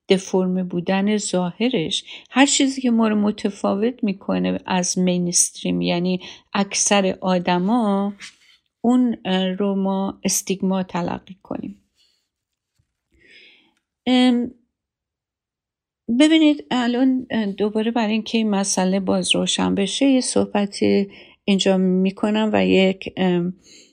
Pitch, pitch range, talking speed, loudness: 200 Hz, 185-235 Hz, 100 wpm, -20 LUFS